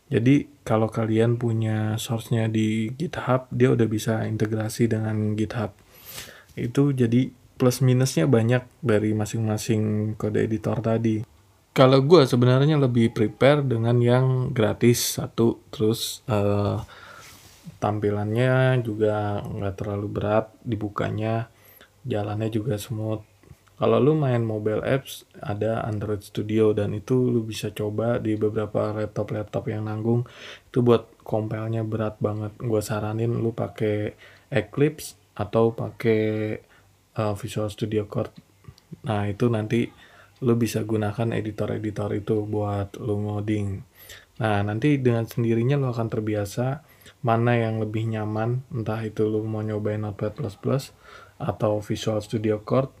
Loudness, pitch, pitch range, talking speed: -24 LUFS, 110 Hz, 105-120 Hz, 125 wpm